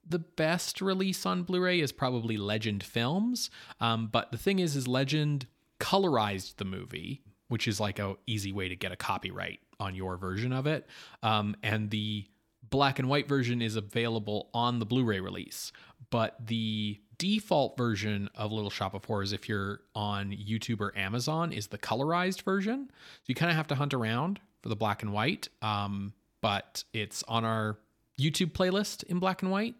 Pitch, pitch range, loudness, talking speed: 115 Hz, 105-155 Hz, -32 LUFS, 180 wpm